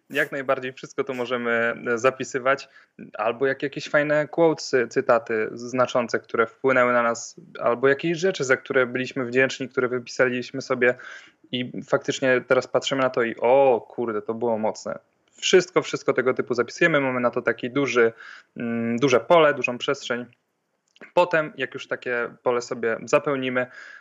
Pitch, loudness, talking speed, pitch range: 130 Hz, -23 LUFS, 150 wpm, 120-140 Hz